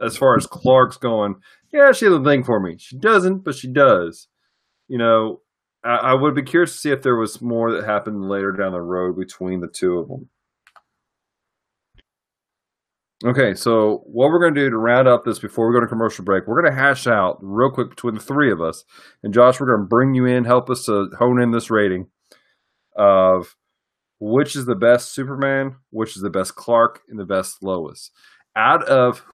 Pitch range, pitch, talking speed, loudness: 105-130 Hz, 120 Hz, 210 wpm, -18 LUFS